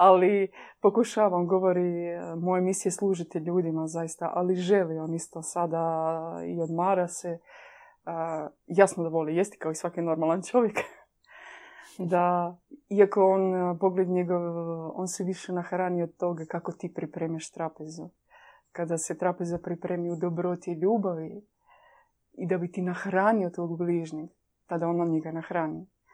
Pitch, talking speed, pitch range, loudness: 175 Hz, 140 wpm, 165-190 Hz, -28 LUFS